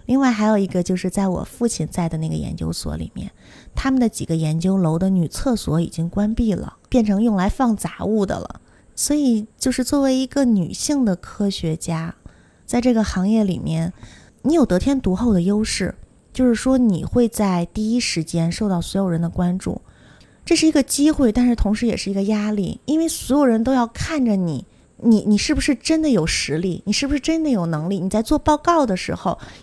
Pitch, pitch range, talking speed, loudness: 210 Hz, 180-255 Hz, 300 characters per minute, -20 LUFS